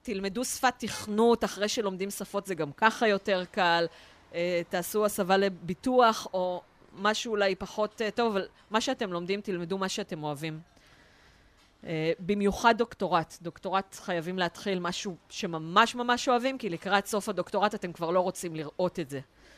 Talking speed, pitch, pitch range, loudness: 155 wpm, 195 Hz, 175-215 Hz, -29 LUFS